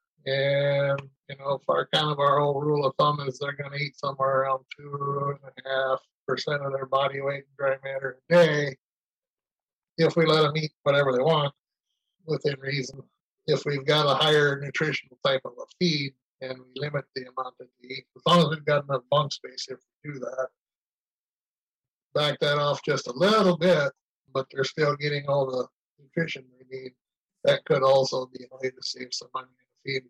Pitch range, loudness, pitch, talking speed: 130-145 Hz, -26 LUFS, 140 Hz, 205 wpm